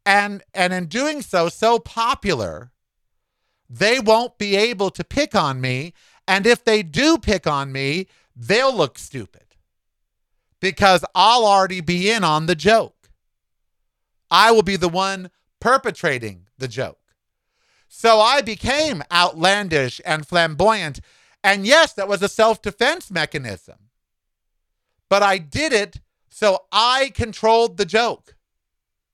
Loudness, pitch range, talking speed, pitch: -18 LUFS, 150-220 Hz, 130 wpm, 190 Hz